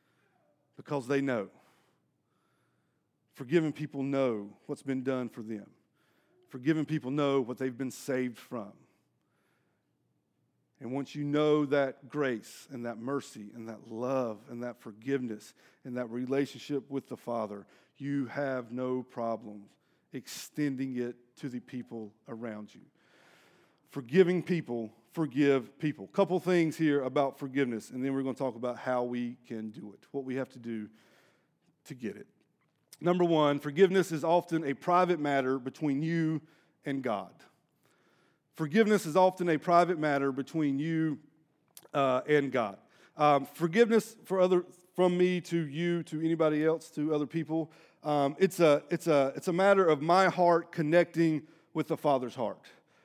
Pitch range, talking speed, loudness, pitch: 125-160 Hz, 150 wpm, -31 LUFS, 140 Hz